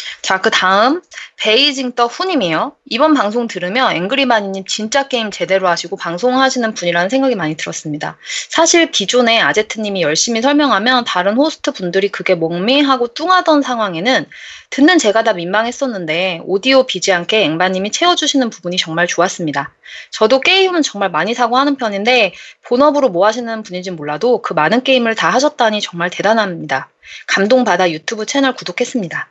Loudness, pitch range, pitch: -14 LUFS, 185-265 Hz, 225 Hz